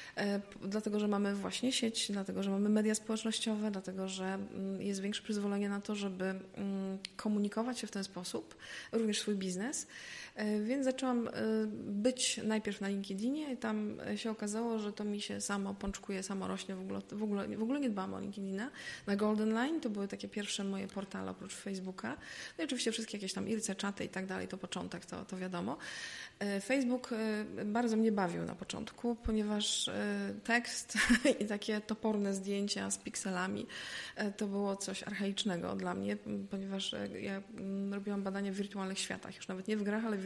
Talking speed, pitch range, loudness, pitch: 170 wpm, 195-220 Hz, -37 LUFS, 205 Hz